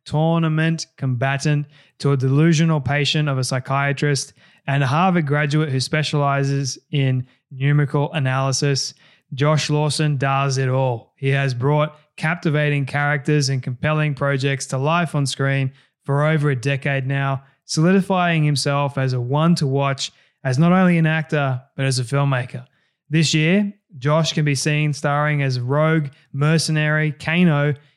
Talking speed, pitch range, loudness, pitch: 145 wpm, 135-155 Hz, -20 LUFS, 145 Hz